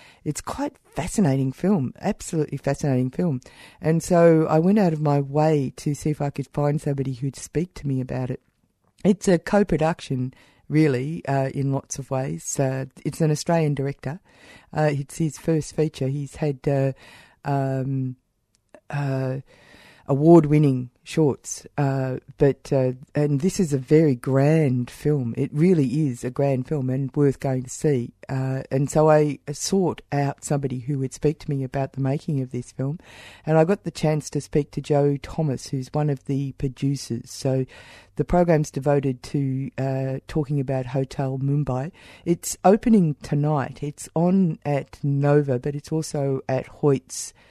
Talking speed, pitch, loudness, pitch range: 165 wpm, 140 Hz, -23 LUFS, 135-155 Hz